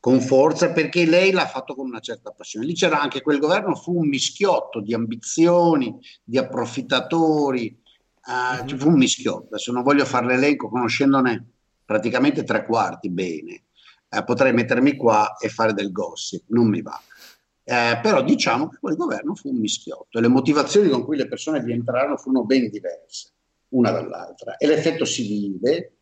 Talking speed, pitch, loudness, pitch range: 170 wpm, 130 Hz, -21 LUFS, 115-150 Hz